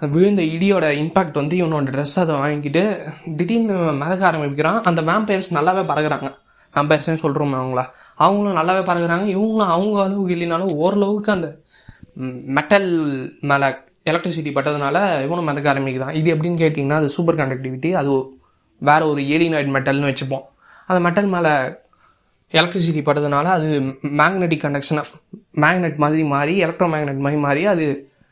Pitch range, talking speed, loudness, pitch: 145-180 Hz, 130 wpm, -18 LUFS, 155 Hz